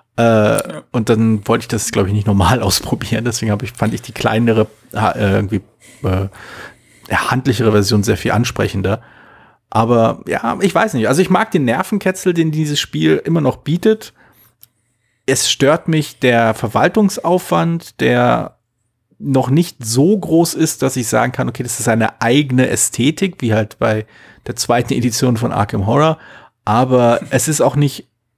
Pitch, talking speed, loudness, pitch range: 120 Hz, 165 wpm, -15 LUFS, 110-145 Hz